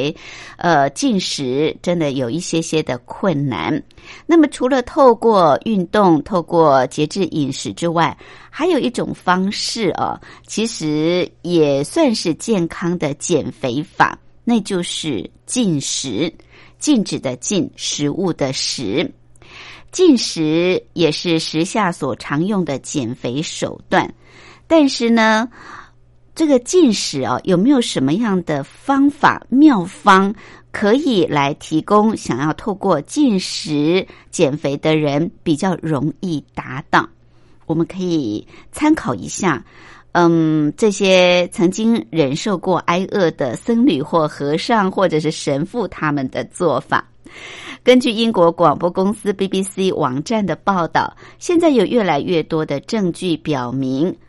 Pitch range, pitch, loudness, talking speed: 155-215 Hz, 175 Hz, -17 LUFS, 195 characters per minute